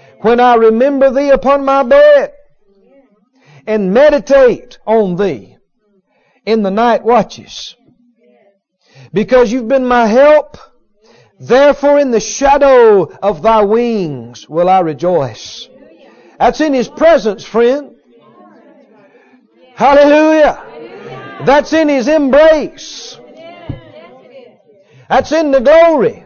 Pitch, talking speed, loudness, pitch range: 255 Hz, 100 wpm, -10 LUFS, 215-285 Hz